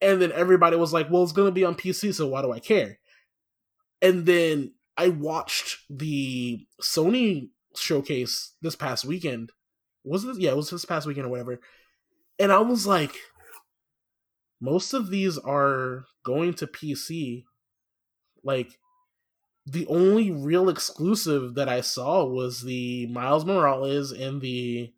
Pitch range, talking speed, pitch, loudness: 130-185 Hz, 150 wpm, 155 Hz, -25 LUFS